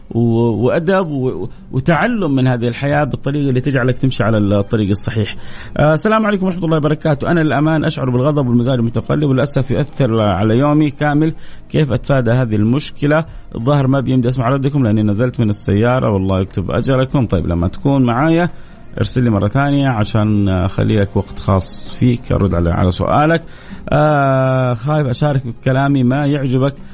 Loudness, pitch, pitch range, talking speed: -15 LUFS, 130 Hz, 115-145 Hz, 150 wpm